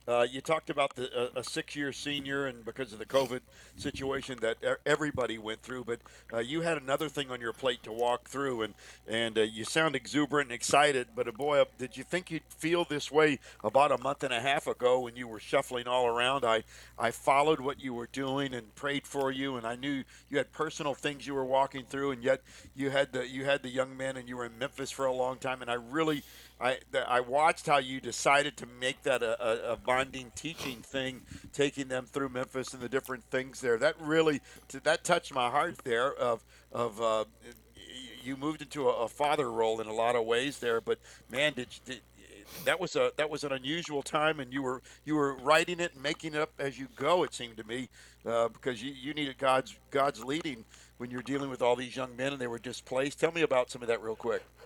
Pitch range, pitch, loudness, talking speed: 125-145 Hz, 135 Hz, -32 LUFS, 230 wpm